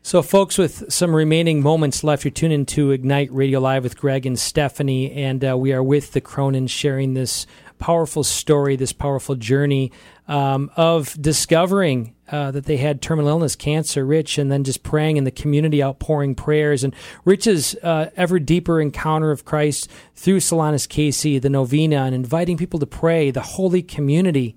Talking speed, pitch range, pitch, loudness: 180 wpm, 135-160 Hz, 145 Hz, -19 LUFS